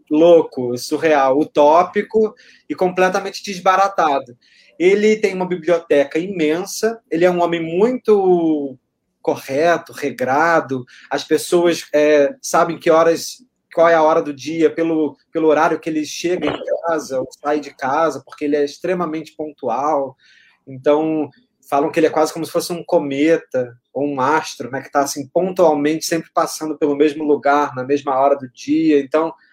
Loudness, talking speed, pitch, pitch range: -17 LUFS, 155 wpm, 155 Hz, 145-175 Hz